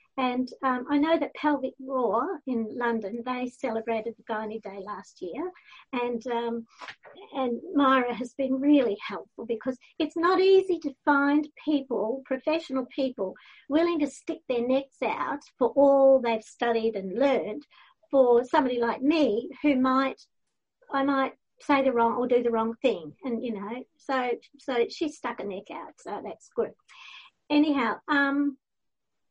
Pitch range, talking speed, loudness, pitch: 235-295 Hz, 155 wpm, -27 LUFS, 265 Hz